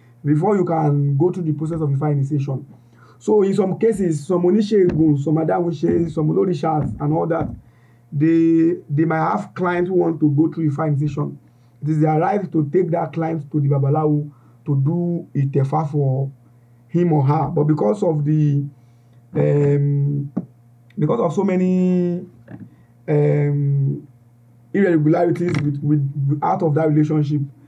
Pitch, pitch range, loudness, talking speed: 150 Hz, 140-170 Hz, -19 LUFS, 160 wpm